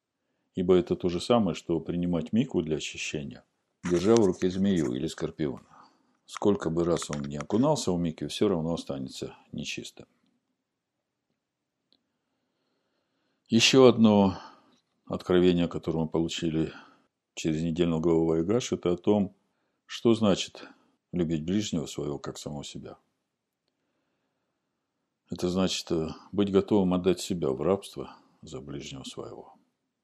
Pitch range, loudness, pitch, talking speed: 80-95 Hz, -27 LUFS, 85 Hz, 120 wpm